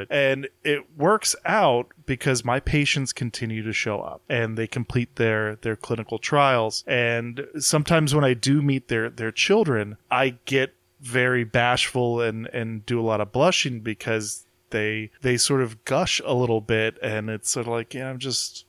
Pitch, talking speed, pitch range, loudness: 120 Hz, 185 wpm, 110-135 Hz, -23 LUFS